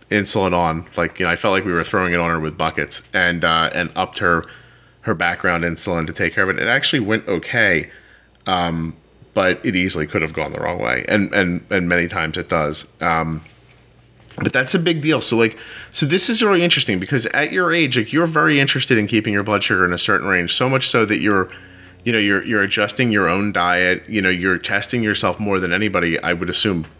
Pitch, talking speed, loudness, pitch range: 95 Hz, 230 wpm, -18 LUFS, 85-115 Hz